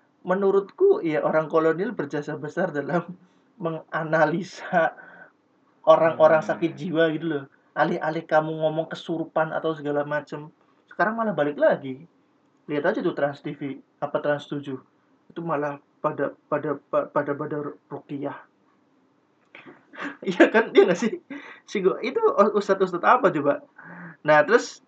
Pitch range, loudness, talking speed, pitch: 150-185 Hz, -24 LUFS, 130 wpm, 160 Hz